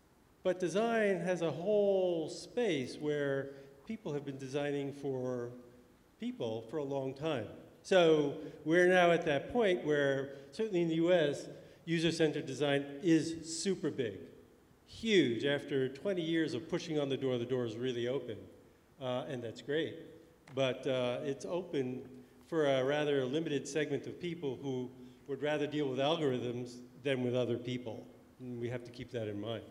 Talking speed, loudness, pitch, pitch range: 165 wpm, -35 LUFS, 140 Hz, 130-165 Hz